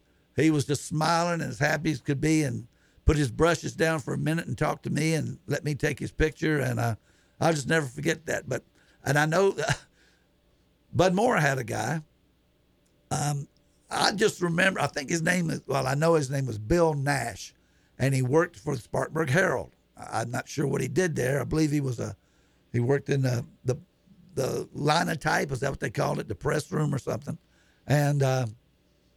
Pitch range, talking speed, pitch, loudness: 130-160 Hz, 210 wpm, 145 Hz, -27 LUFS